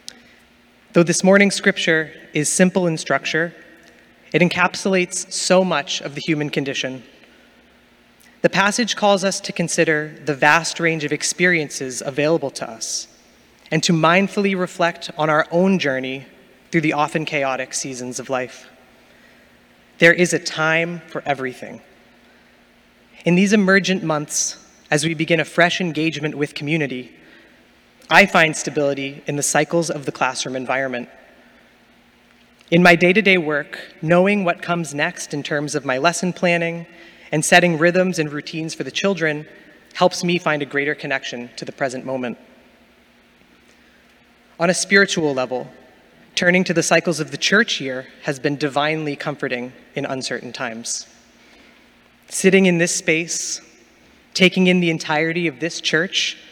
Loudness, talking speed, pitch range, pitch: -18 LUFS, 145 wpm, 145-175 Hz, 160 Hz